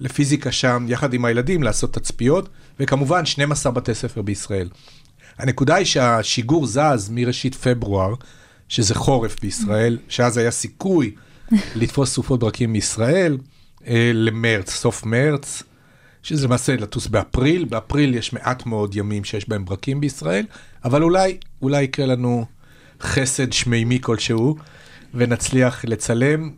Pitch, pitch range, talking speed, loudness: 125 Hz, 115-140 Hz, 120 wpm, -20 LUFS